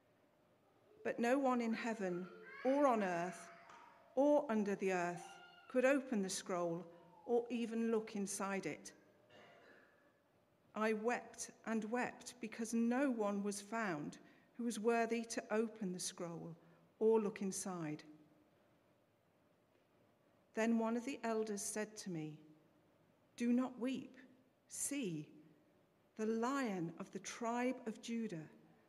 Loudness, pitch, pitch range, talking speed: -40 LUFS, 220 Hz, 185-240 Hz, 125 wpm